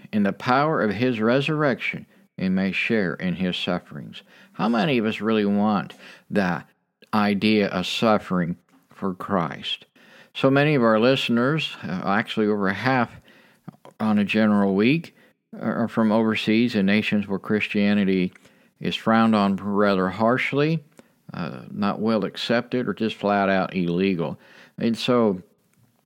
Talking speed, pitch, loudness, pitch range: 135 wpm, 110 Hz, -22 LUFS, 100-120 Hz